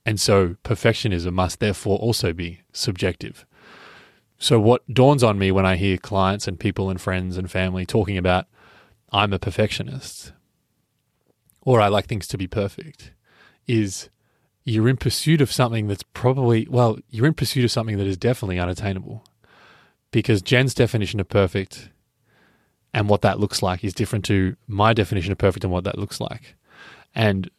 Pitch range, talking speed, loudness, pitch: 95-120 Hz, 165 wpm, -21 LUFS, 105 Hz